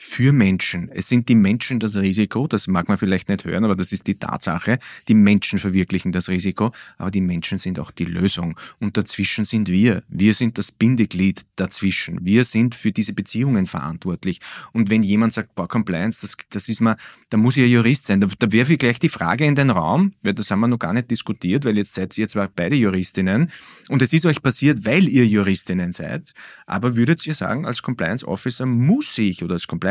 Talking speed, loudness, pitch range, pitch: 215 wpm, -19 LUFS, 95-120 Hz, 110 Hz